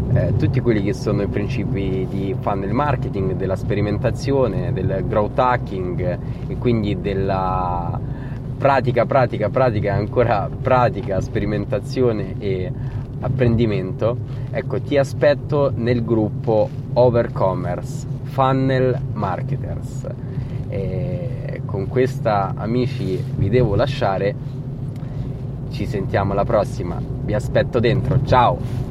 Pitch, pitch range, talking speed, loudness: 125 Hz, 120-135 Hz, 100 wpm, -20 LUFS